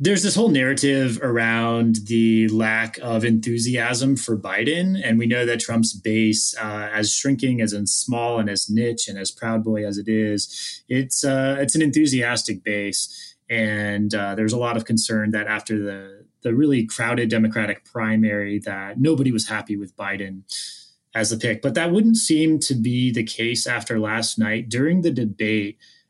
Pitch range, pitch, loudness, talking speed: 110-125 Hz, 115 Hz, -21 LUFS, 175 wpm